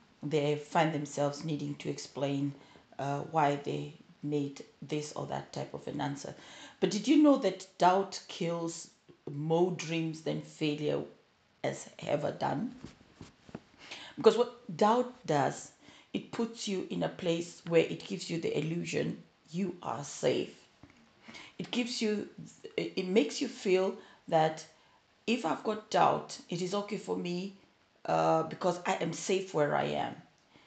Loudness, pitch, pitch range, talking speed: -33 LUFS, 175 Hz, 150-205 Hz, 145 wpm